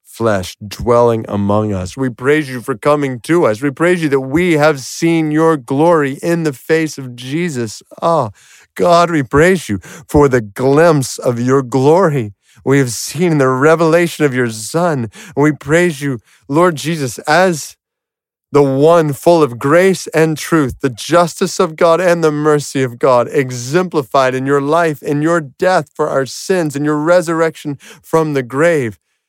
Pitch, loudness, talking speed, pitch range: 150 Hz, -14 LUFS, 170 wpm, 130-170 Hz